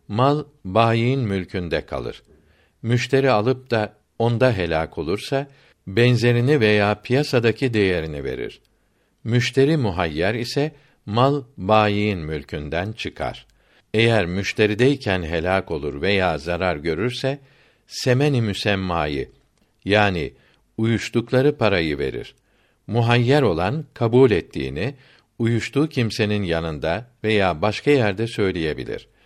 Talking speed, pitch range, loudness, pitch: 95 wpm, 95-125 Hz, -21 LUFS, 110 Hz